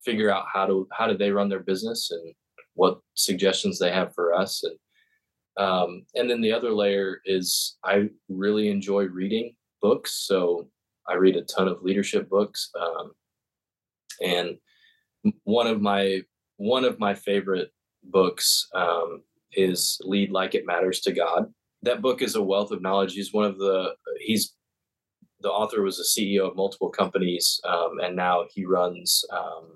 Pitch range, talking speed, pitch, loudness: 95-110 Hz, 165 wpm, 100 Hz, -25 LUFS